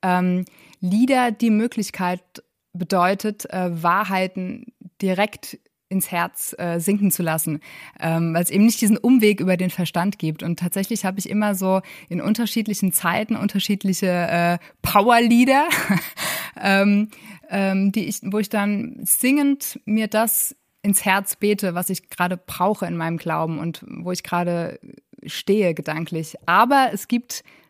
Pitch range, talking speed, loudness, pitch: 180-215 Hz, 145 wpm, -21 LUFS, 195 Hz